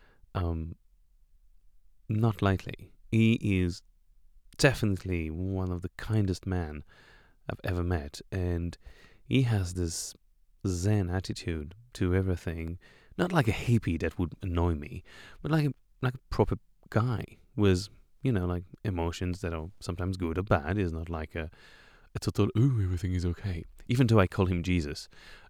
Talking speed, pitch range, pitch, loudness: 150 wpm, 85-105 Hz, 90 Hz, -31 LUFS